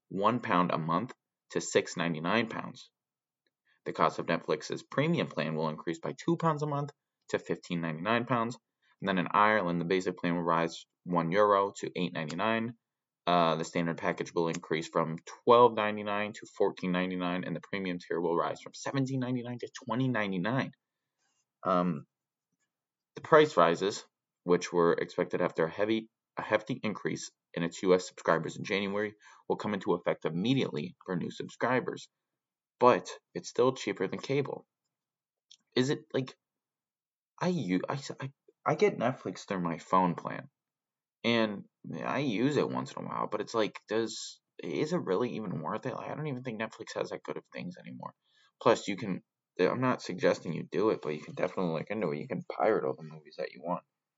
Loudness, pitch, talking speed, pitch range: -31 LUFS, 100 Hz, 175 wpm, 85-120 Hz